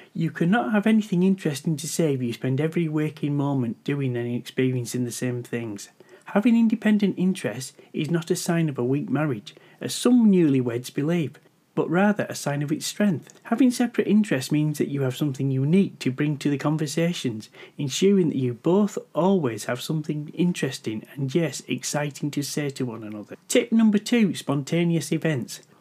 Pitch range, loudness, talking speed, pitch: 130-185 Hz, -24 LUFS, 175 wpm, 155 Hz